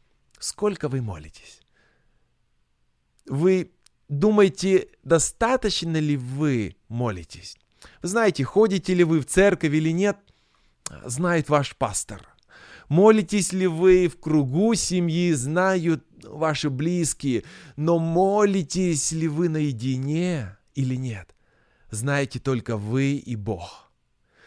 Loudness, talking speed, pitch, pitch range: -23 LUFS, 105 wpm, 155 Hz, 130-185 Hz